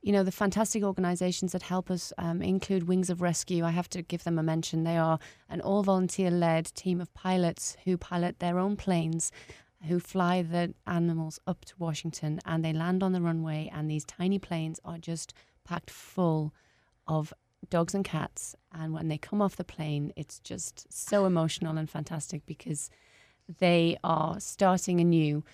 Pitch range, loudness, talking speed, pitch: 160-185 Hz, -30 LUFS, 180 wpm, 170 Hz